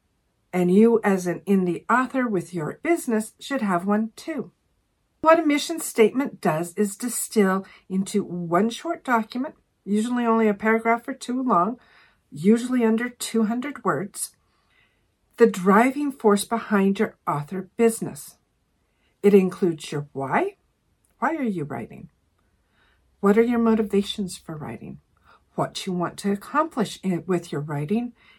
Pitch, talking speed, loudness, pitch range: 215 Hz, 135 wpm, -23 LUFS, 180-240 Hz